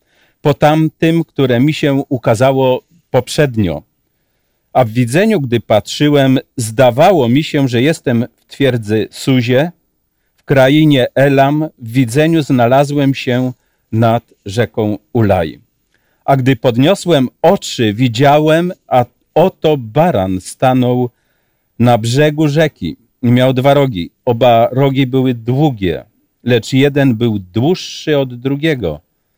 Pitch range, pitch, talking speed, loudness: 120-145 Hz, 130 Hz, 110 wpm, -13 LUFS